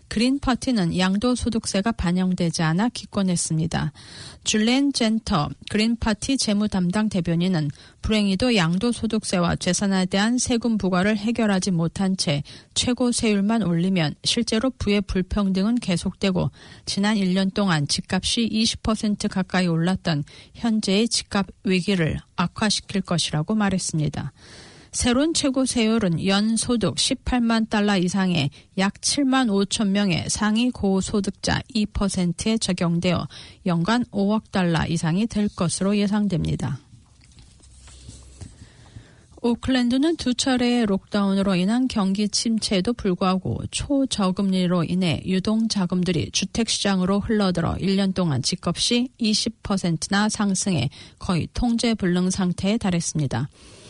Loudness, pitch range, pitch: -22 LUFS, 180-225 Hz, 195 Hz